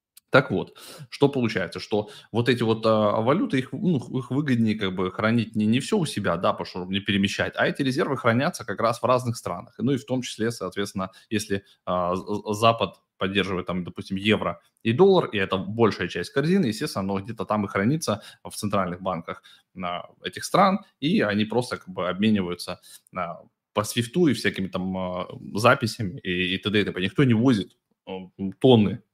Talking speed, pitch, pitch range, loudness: 190 wpm, 105 Hz, 95-120 Hz, -24 LUFS